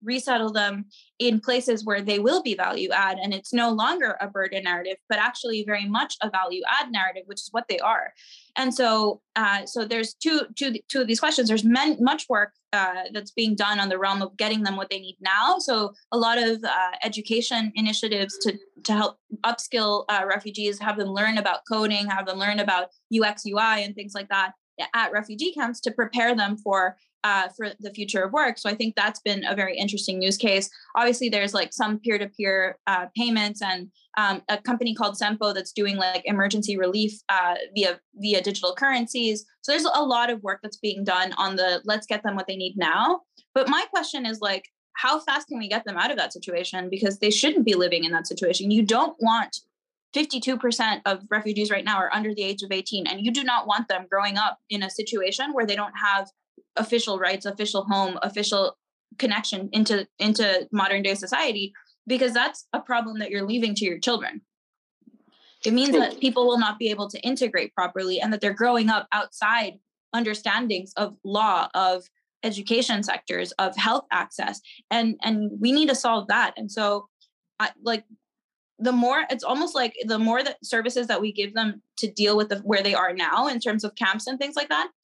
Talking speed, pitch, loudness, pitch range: 205 wpm, 210 Hz, -24 LUFS, 195-235 Hz